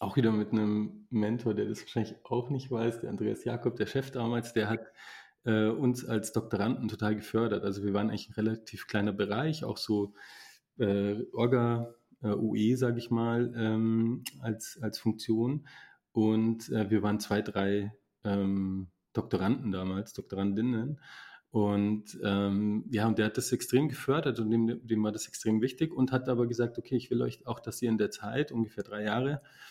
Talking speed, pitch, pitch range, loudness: 180 wpm, 110 Hz, 105-120 Hz, -31 LUFS